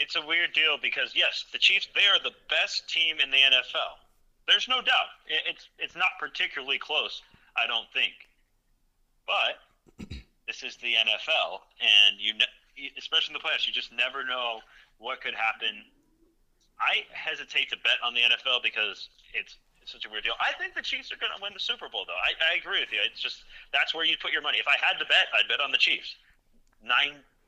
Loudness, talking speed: -25 LUFS, 205 wpm